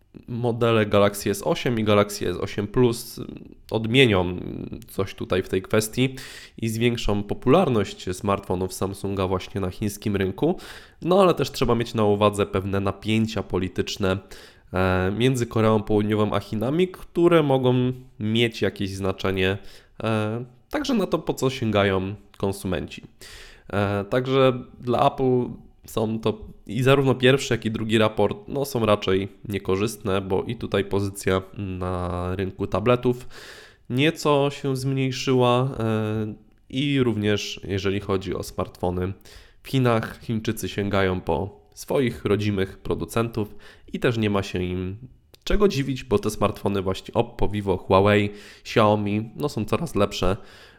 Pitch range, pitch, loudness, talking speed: 95-120 Hz, 105 Hz, -24 LUFS, 130 wpm